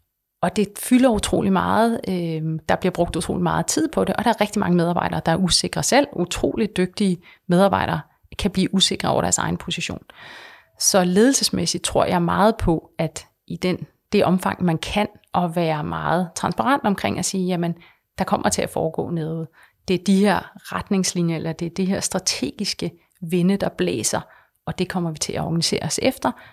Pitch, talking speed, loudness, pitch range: 185 Hz, 190 wpm, -21 LUFS, 170-205 Hz